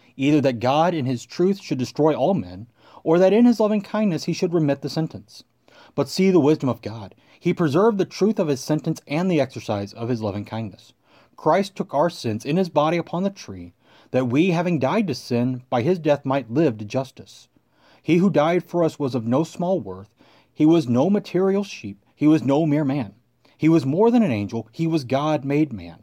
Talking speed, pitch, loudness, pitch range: 220 wpm, 150 Hz, -21 LUFS, 125-175 Hz